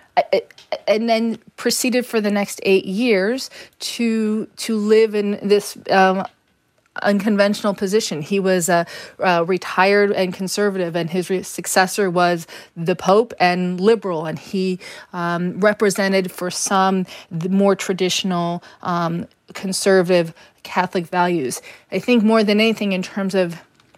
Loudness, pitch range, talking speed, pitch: -19 LUFS, 180-210 Hz, 140 wpm, 195 Hz